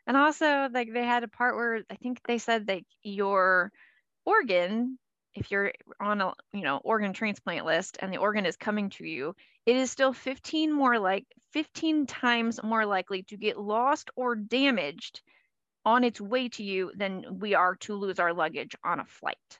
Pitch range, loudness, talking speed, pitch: 200-250 Hz, -28 LUFS, 185 wpm, 225 Hz